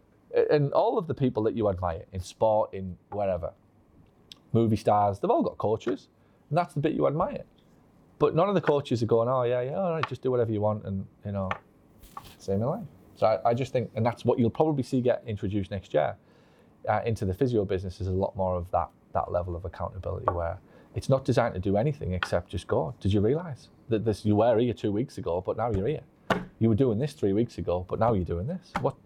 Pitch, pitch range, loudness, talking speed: 110 Hz, 95-130 Hz, -28 LUFS, 230 wpm